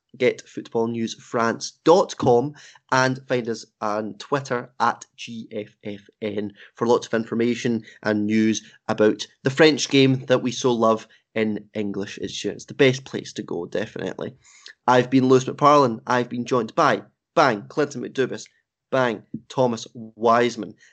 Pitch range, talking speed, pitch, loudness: 110-125 Hz, 130 wpm, 115 Hz, -22 LUFS